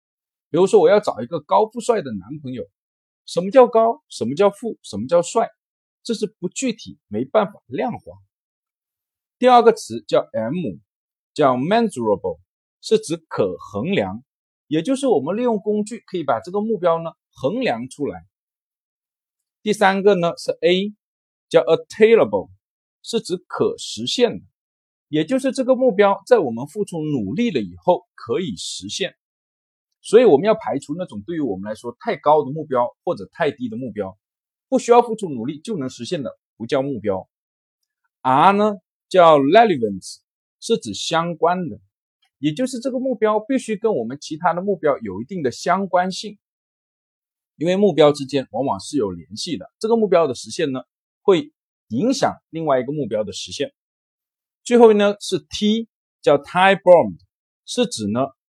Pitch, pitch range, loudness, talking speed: 200 Hz, 155-235 Hz, -19 LUFS, 265 characters per minute